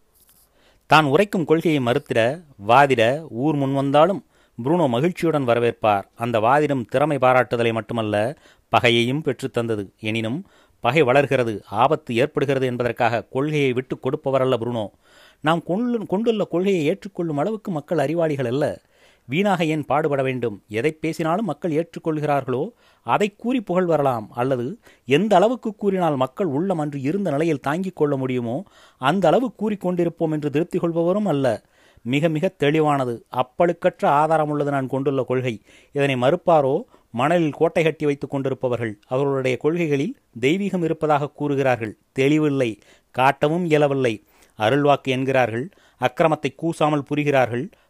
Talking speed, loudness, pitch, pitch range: 120 wpm, -21 LUFS, 145 Hz, 125-165 Hz